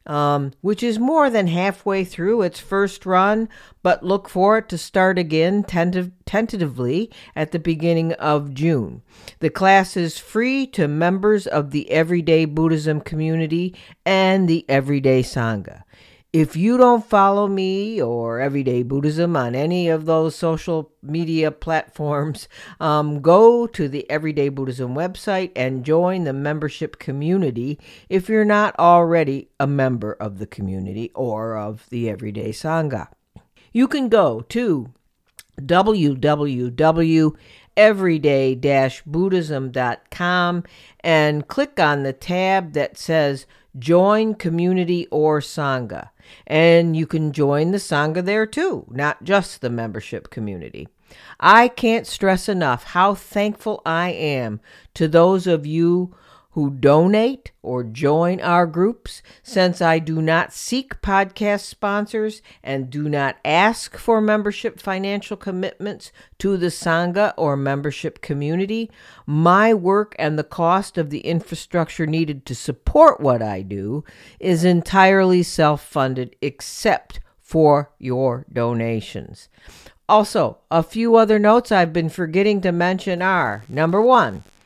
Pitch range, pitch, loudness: 145-195 Hz, 165 Hz, -19 LUFS